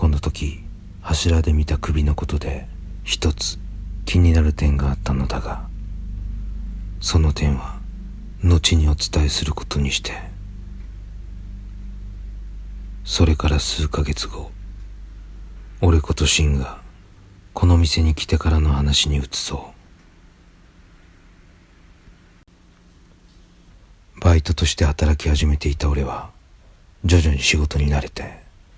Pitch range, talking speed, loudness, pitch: 75-90 Hz, 195 characters per minute, -20 LUFS, 85 Hz